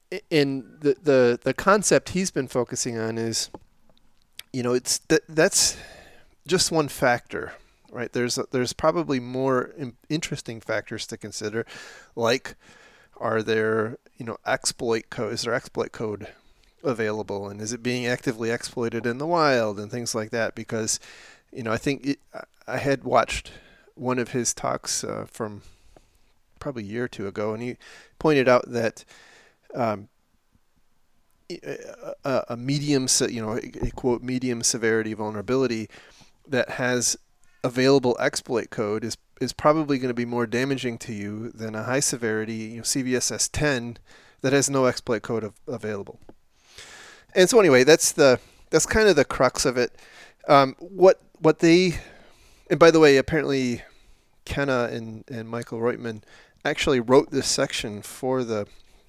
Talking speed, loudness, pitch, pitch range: 155 wpm, -24 LUFS, 125 Hz, 115-140 Hz